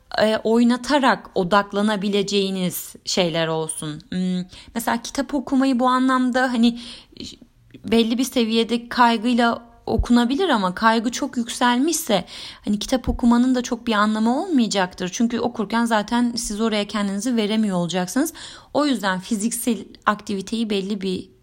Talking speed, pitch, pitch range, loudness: 115 wpm, 230 Hz, 205-245 Hz, -21 LUFS